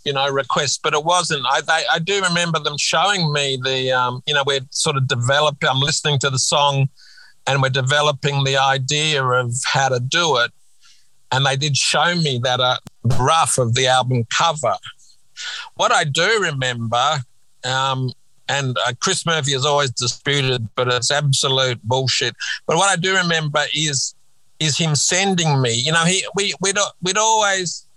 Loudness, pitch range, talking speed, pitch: -18 LUFS, 130-160 Hz, 180 wpm, 140 Hz